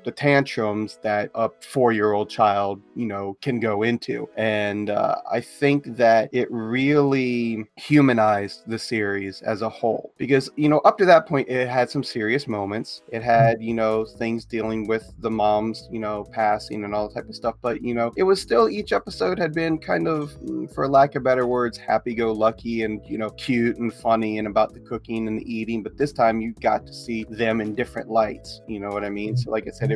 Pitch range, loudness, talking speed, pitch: 110-125 Hz, -23 LUFS, 210 wpm, 115 Hz